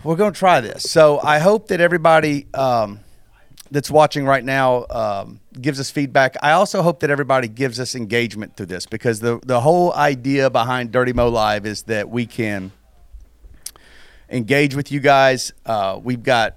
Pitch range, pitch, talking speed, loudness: 115-145 Hz, 130 Hz, 180 wpm, -17 LUFS